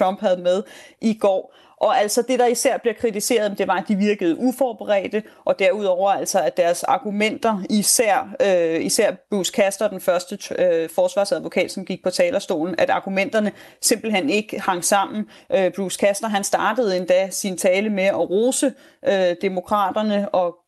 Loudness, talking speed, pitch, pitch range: -20 LUFS, 165 wpm, 205 Hz, 190-230 Hz